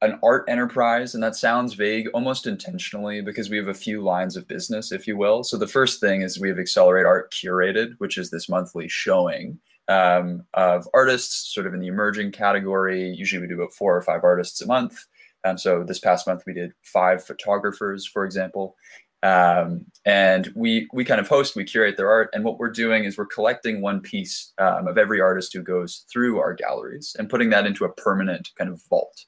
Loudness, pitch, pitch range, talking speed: -22 LUFS, 100 Hz, 95-115 Hz, 215 wpm